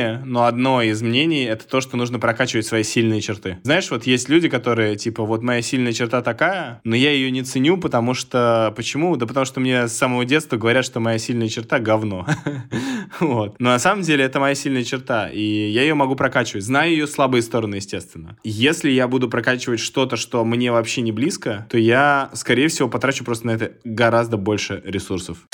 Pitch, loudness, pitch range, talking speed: 120 Hz, -19 LUFS, 115-135 Hz, 195 wpm